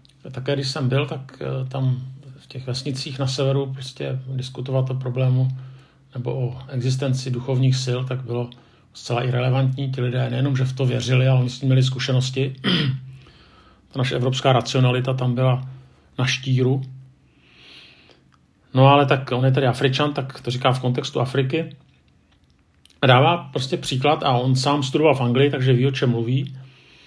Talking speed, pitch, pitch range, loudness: 160 wpm, 130 Hz, 125-135 Hz, -21 LUFS